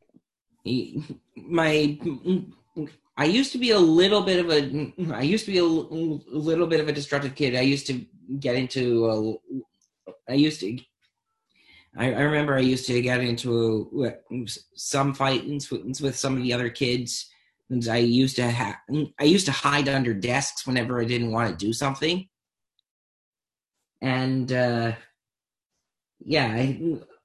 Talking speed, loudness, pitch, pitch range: 150 wpm, -24 LUFS, 135 Hz, 120-155 Hz